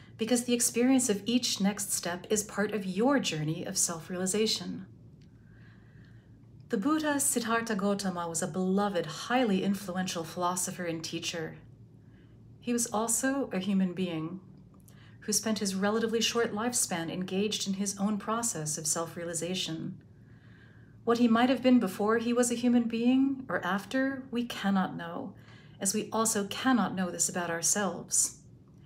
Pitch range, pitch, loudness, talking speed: 170-230 Hz, 200 Hz, -29 LUFS, 145 wpm